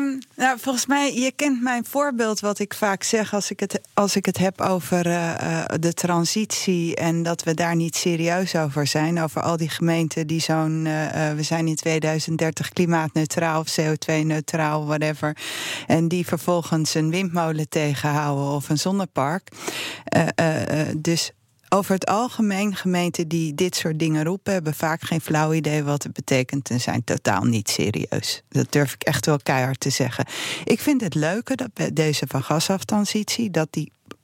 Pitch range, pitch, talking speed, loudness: 155-190 Hz, 165 Hz, 175 wpm, -22 LUFS